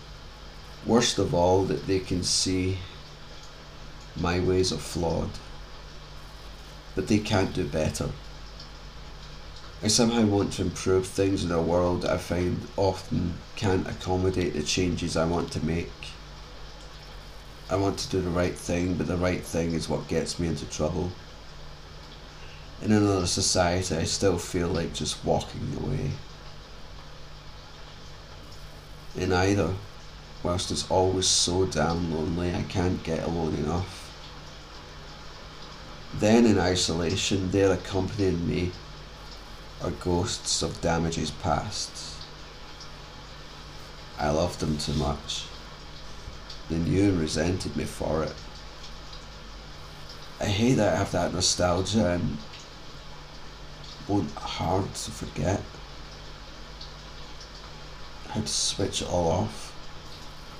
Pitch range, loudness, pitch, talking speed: 75-95 Hz, -27 LUFS, 85 Hz, 120 wpm